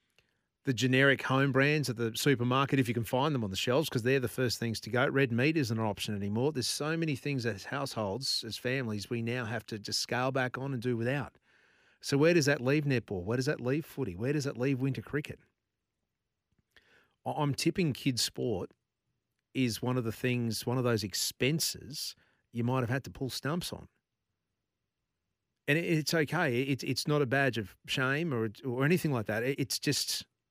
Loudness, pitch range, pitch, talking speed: -31 LUFS, 115-140 Hz, 130 Hz, 195 wpm